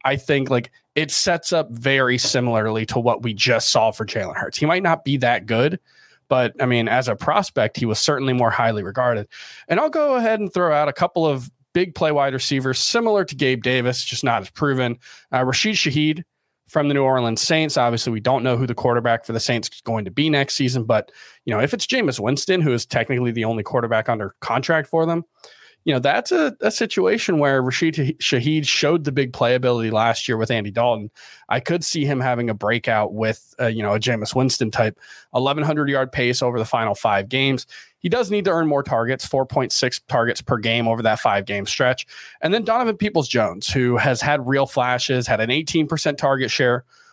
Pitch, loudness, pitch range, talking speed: 130 Hz, -20 LUFS, 120-150 Hz, 215 wpm